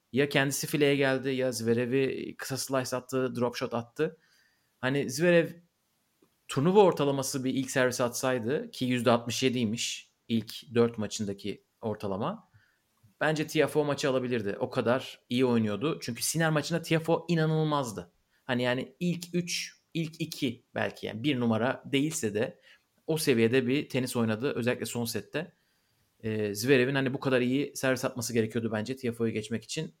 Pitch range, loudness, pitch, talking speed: 120-150 Hz, -29 LUFS, 130 Hz, 145 wpm